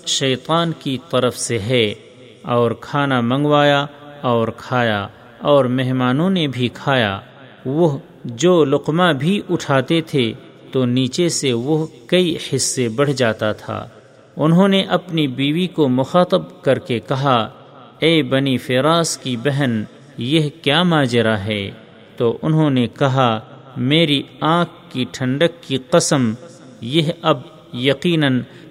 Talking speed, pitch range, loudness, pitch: 130 wpm, 125-160 Hz, -18 LUFS, 135 Hz